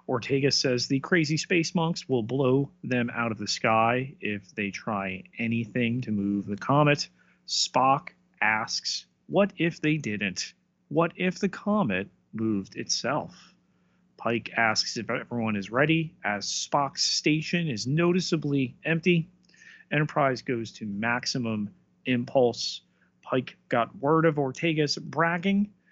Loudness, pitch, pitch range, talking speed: -27 LUFS, 135 Hz, 115-165 Hz, 130 wpm